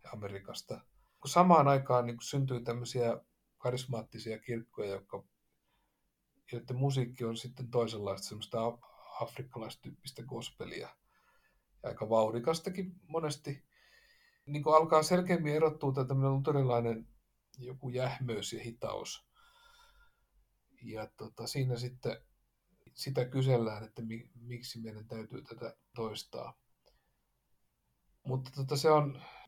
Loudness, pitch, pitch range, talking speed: -34 LUFS, 125 Hz, 115-145 Hz, 105 wpm